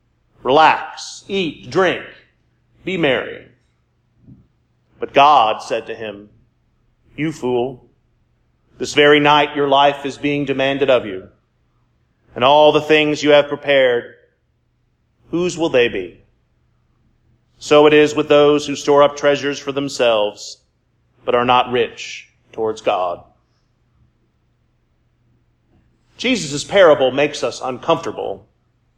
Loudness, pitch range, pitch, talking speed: -15 LUFS, 120-150 Hz, 140 Hz, 115 wpm